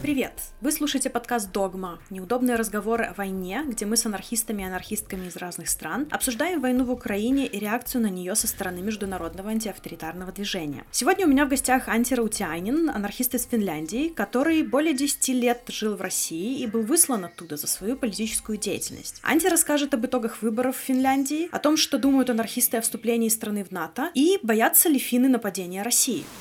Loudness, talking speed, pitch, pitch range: -24 LUFS, 180 wpm, 235 Hz, 200-265 Hz